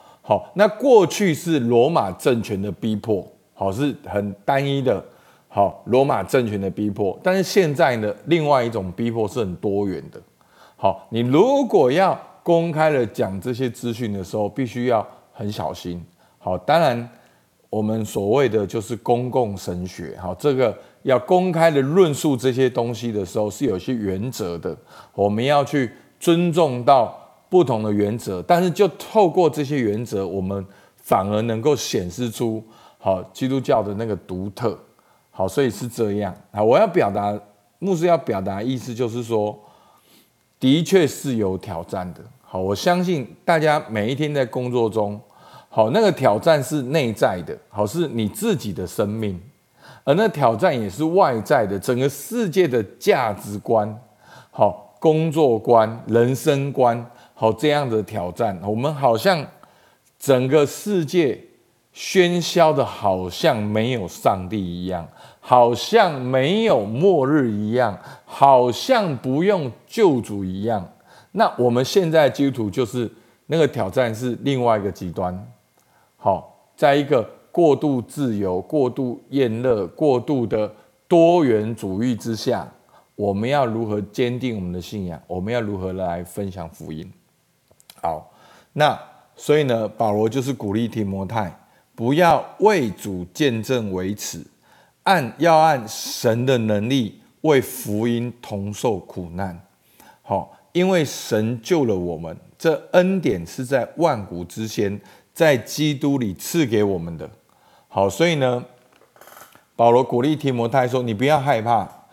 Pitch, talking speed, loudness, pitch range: 120 Hz, 215 characters per minute, -20 LUFS, 105-145 Hz